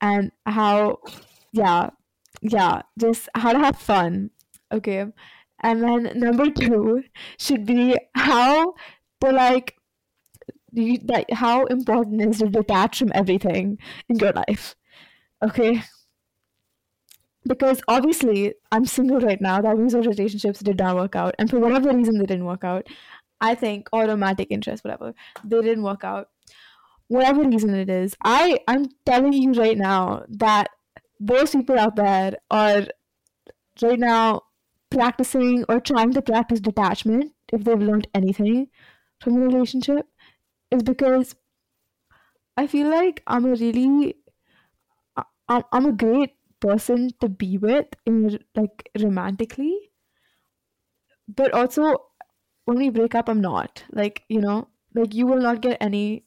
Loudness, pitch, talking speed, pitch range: -21 LUFS, 230 Hz, 135 wpm, 210-255 Hz